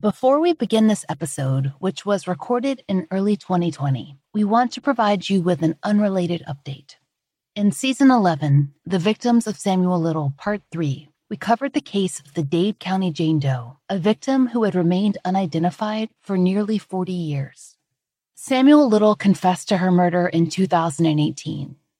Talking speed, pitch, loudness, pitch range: 160 wpm, 185 Hz, -20 LUFS, 160-210 Hz